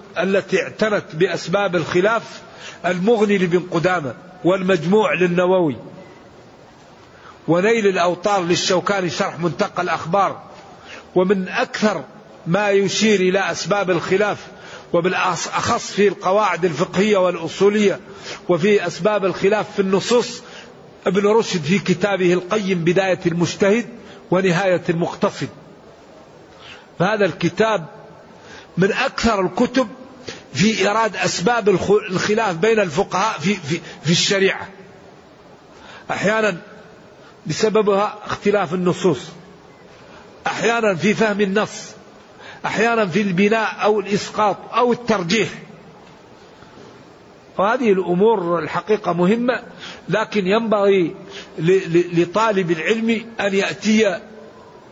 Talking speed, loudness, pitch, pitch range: 85 wpm, -18 LUFS, 200 Hz, 180-215 Hz